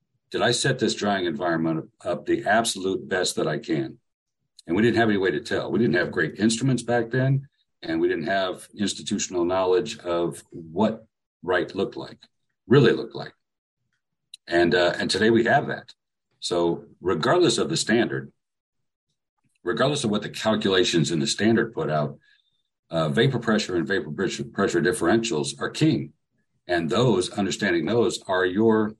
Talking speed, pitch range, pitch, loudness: 165 wpm, 90-130 Hz, 110 Hz, -23 LUFS